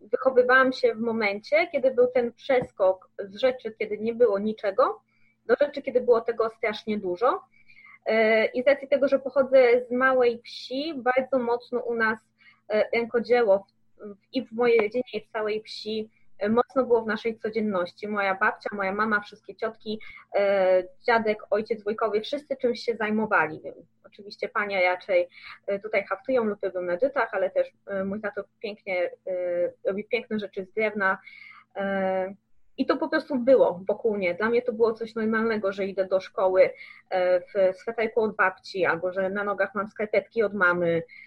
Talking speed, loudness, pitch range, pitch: 155 wpm, -25 LUFS, 200-250 Hz, 220 Hz